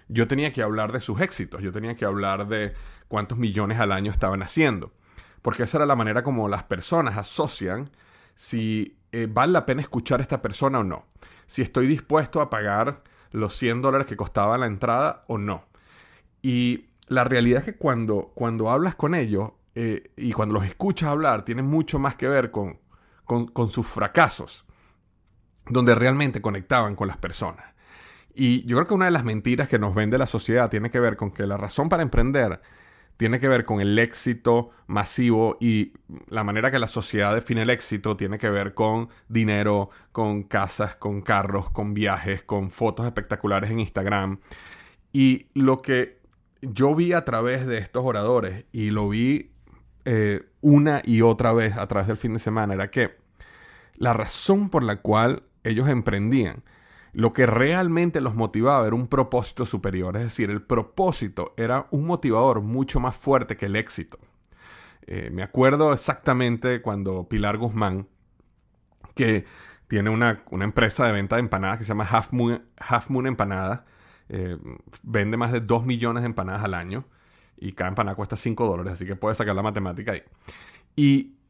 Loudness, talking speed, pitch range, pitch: -24 LUFS, 175 wpm, 100-125 Hz, 115 Hz